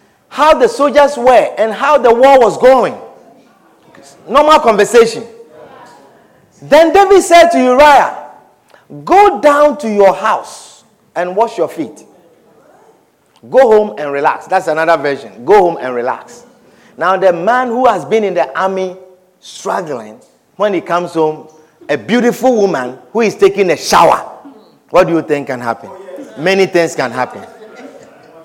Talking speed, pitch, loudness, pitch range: 145 wpm, 220 Hz, -11 LUFS, 175-275 Hz